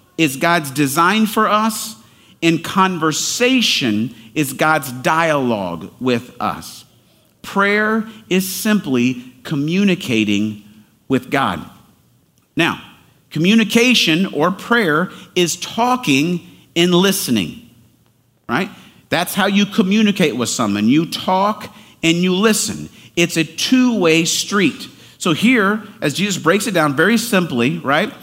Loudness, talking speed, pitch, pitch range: -16 LUFS, 115 wpm, 175 Hz, 150-215 Hz